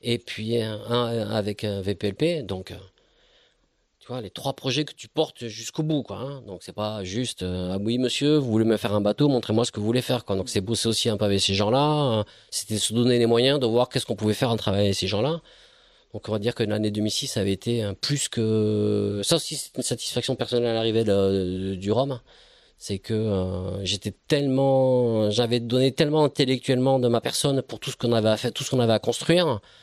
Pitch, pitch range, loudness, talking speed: 115 Hz, 105-130 Hz, -24 LUFS, 225 wpm